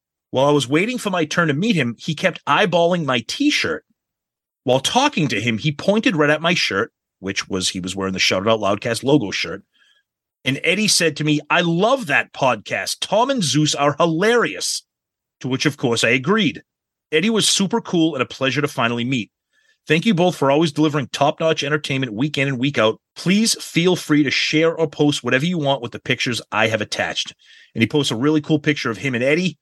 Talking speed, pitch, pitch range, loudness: 215 wpm, 150 Hz, 130-170 Hz, -19 LUFS